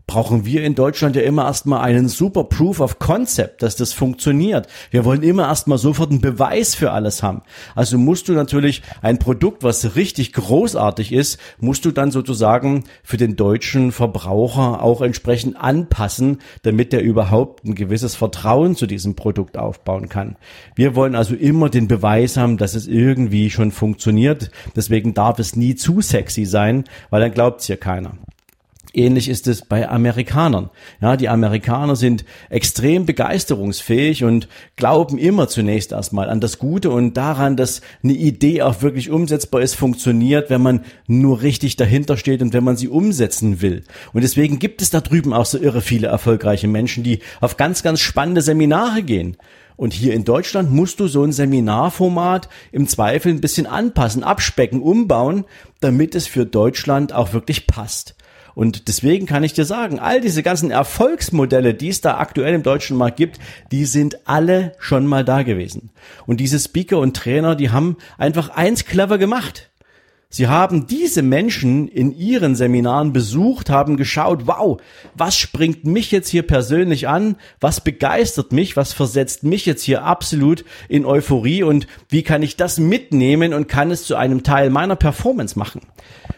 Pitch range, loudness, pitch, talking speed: 115-155 Hz, -17 LUFS, 130 Hz, 170 wpm